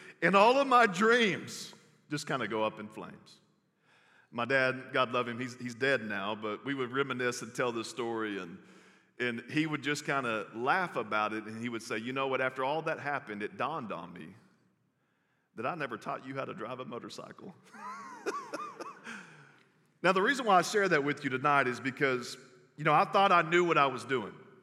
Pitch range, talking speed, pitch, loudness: 120-160 Hz, 210 wpm, 135 Hz, -31 LUFS